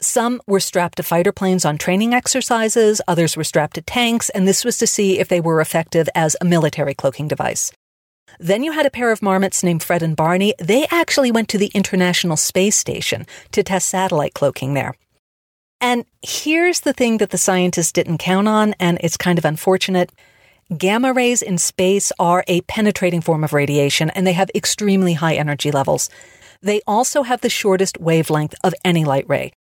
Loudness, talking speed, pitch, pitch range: -17 LUFS, 190 wpm, 185 Hz, 165-210 Hz